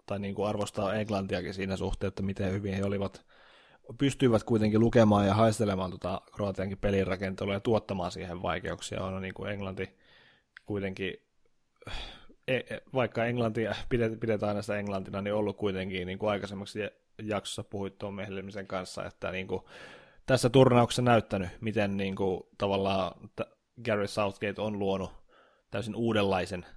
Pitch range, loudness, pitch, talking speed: 95-105 Hz, -31 LUFS, 100 Hz, 135 wpm